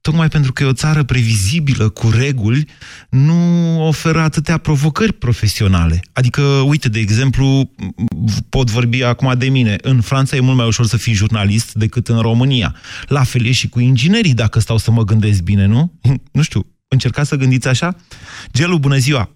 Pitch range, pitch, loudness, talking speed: 115-145 Hz, 125 Hz, -14 LUFS, 175 wpm